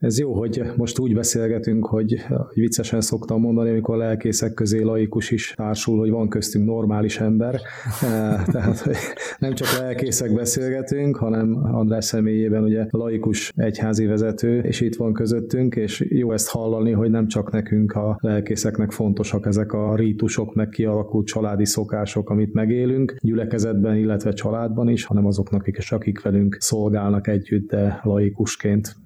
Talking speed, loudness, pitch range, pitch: 150 wpm, -21 LUFS, 105-115 Hz, 110 Hz